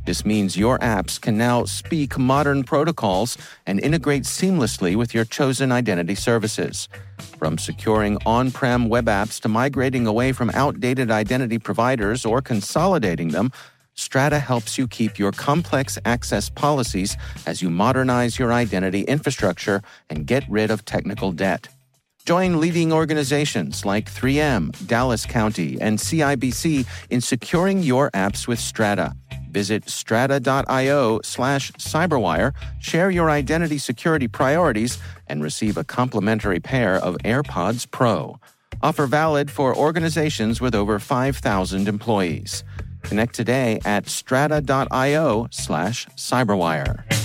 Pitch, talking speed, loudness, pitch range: 120 Hz, 125 wpm, -21 LUFS, 105-140 Hz